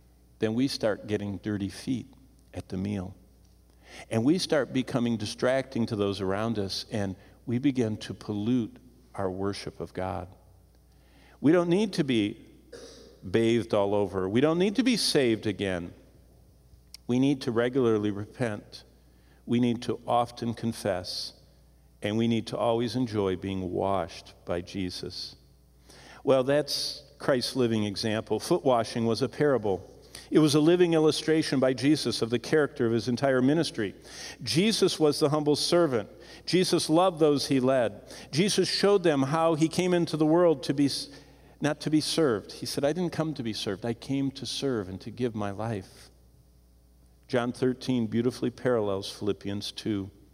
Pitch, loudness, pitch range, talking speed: 115 Hz, -27 LUFS, 100-145 Hz, 160 wpm